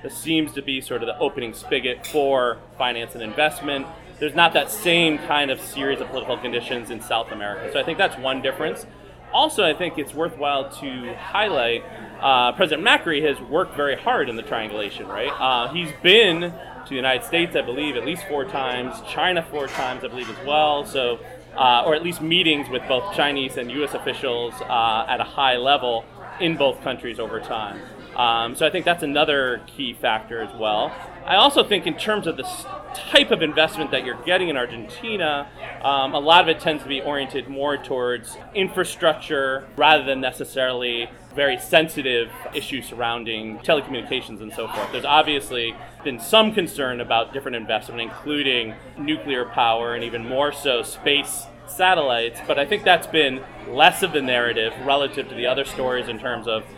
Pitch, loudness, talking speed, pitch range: 140 Hz, -21 LUFS, 185 wpm, 125-155 Hz